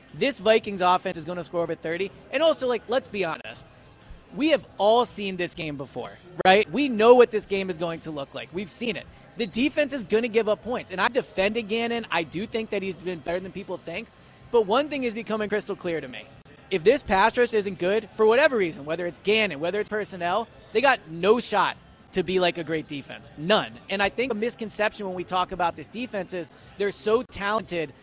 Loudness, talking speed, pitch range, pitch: -25 LUFS, 230 wpm, 175-225 Hz, 200 Hz